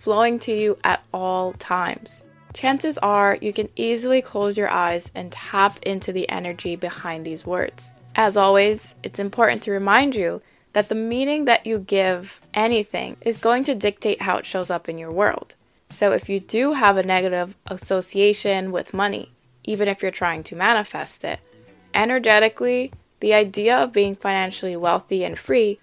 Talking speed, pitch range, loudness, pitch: 170 wpm, 185-220 Hz, -21 LUFS, 200 Hz